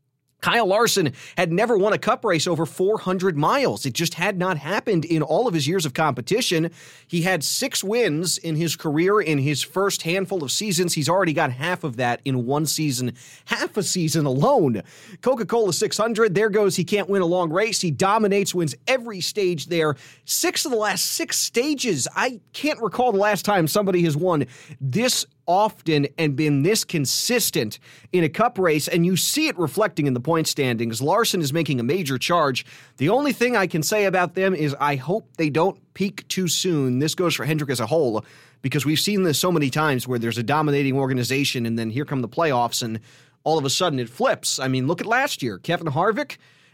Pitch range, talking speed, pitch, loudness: 140-195 Hz, 210 wpm, 165 Hz, -22 LUFS